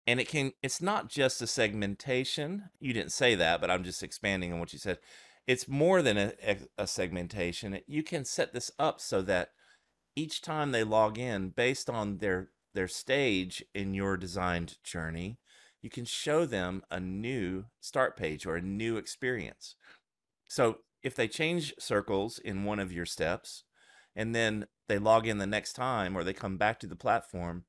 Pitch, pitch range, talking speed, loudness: 105 Hz, 95-130 Hz, 180 wpm, -32 LUFS